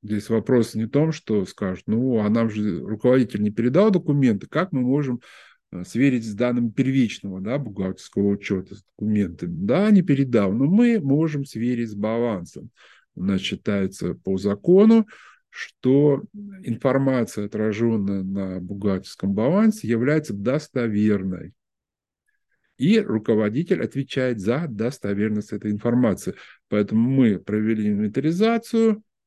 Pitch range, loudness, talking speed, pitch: 105-145 Hz, -22 LUFS, 120 wpm, 115 Hz